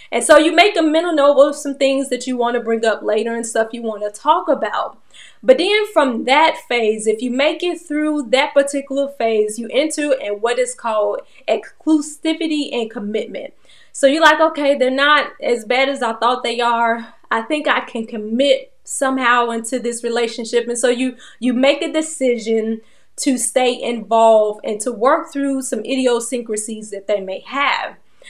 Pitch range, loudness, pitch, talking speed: 230-290 Hz, -17 LUFS, 255 Hz, 185 wpm